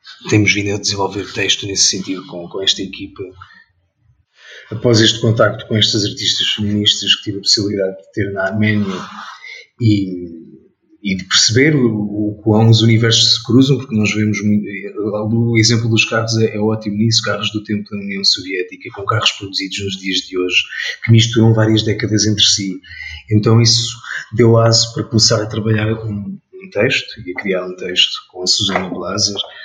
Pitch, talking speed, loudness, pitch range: 105 Hz, 190 wpm, -14 LUFS, 100-115 Hz